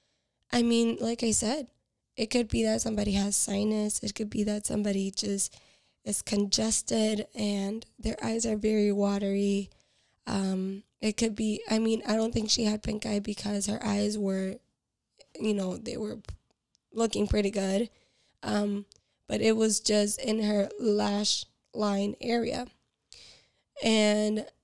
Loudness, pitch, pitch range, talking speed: -29 LUFS, 215 Hz, 205-225 Hz, 150 wpm